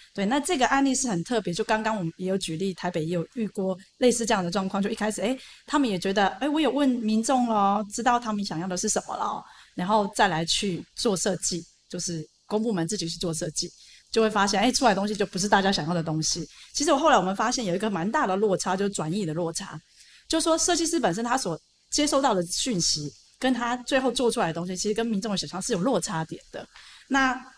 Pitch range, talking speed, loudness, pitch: 175-240 Hz, 355 characters per minute, -25 LUFS, 205 Hz